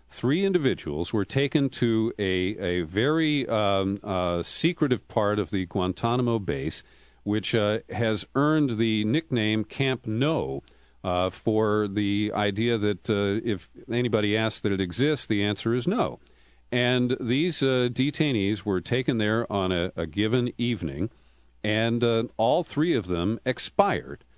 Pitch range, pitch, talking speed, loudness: 100-125 Hz, 110 Hz, 145 wpm, -26 LUFS